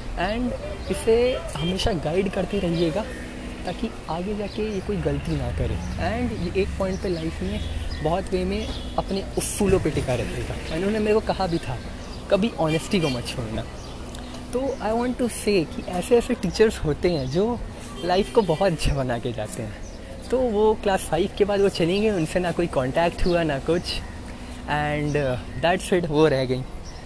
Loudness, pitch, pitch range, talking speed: -24 LUFS, 170 Hz, 130-200 Hz, 175 wpm